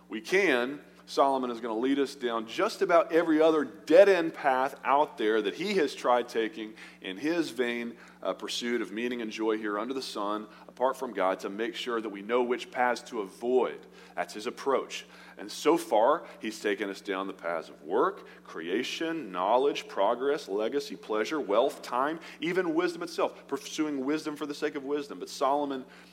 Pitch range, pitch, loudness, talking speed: 110-160 Hz, 130 Hz, -29 LUFS, 190 wpm